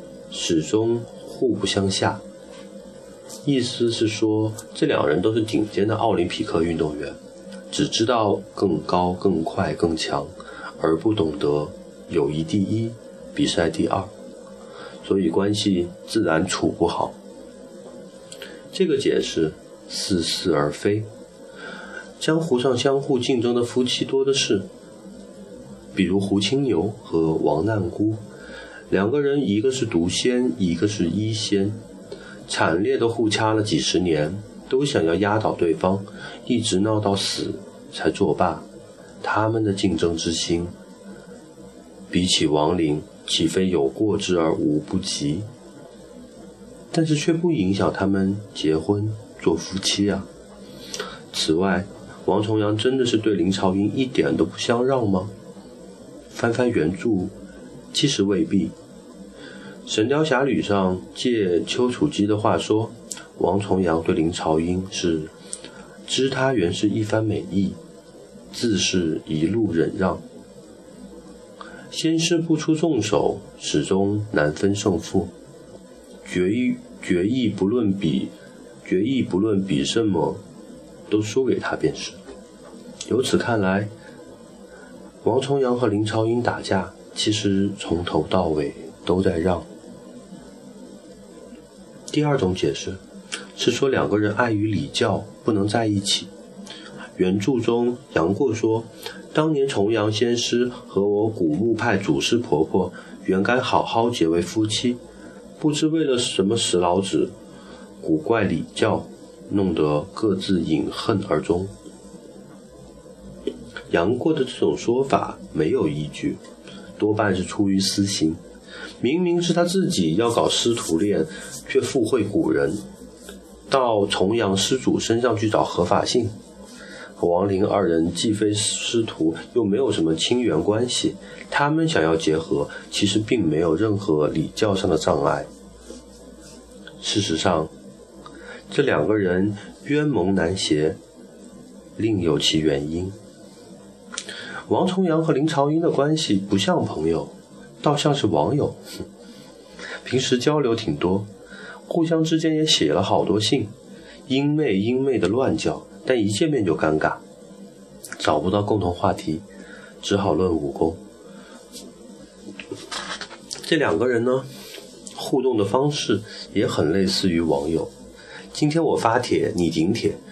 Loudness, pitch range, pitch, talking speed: -22 LUFS, 95-125 Hz, 105 Hz, 185 characters per minute